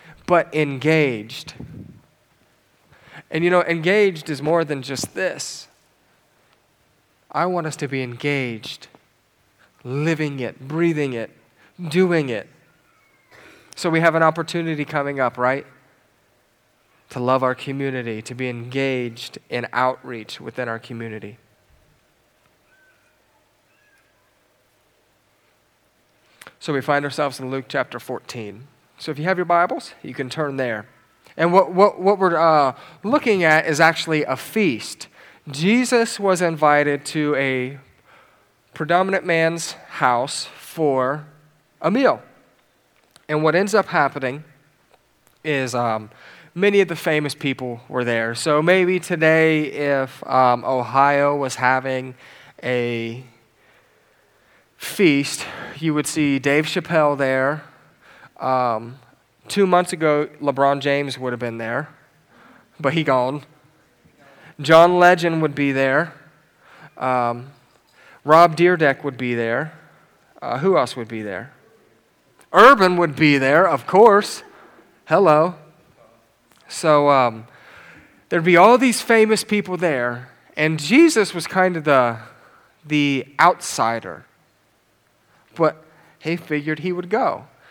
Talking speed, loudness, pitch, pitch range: 120 wpm, -19 LUFS, 145 Hz, 125-165 Hz